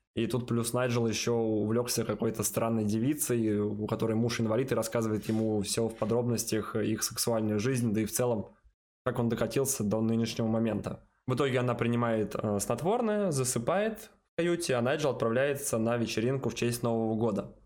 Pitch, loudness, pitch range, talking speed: 115 Hz, -30 LUFS, 110-125 Hz, 170 wpm